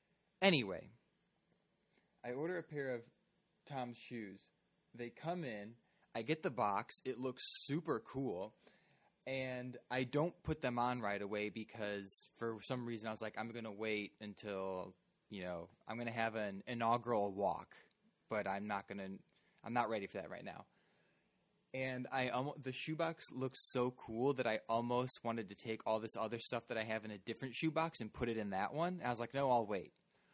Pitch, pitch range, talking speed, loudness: 120 Hz, 110-130 Hz, 190 wpm, -42 LUFS